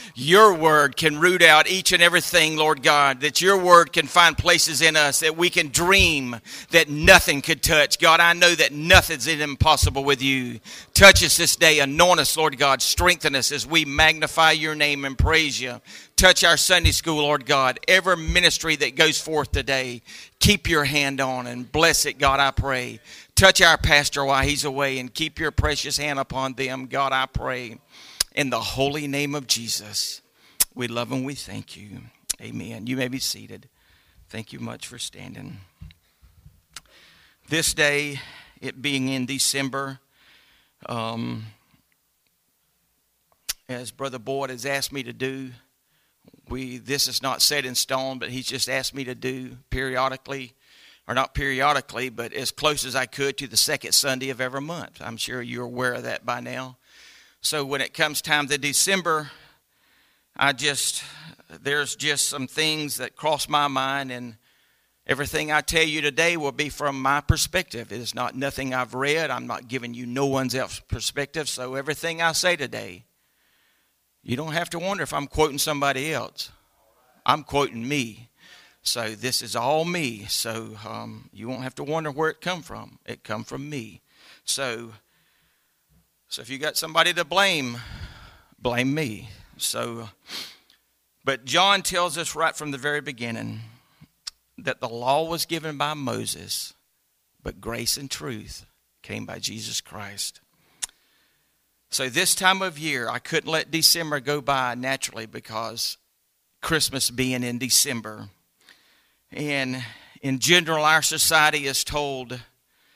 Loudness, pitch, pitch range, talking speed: -21 LUFS, 135 Hz, 125-155 Hz, 160 wpm